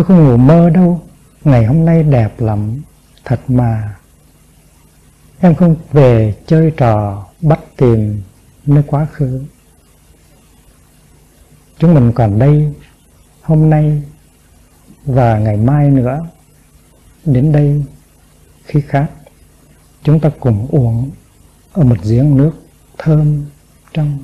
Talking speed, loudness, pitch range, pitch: 115 wpm, -12 LUFS, 115-155 Hz, 140 Hz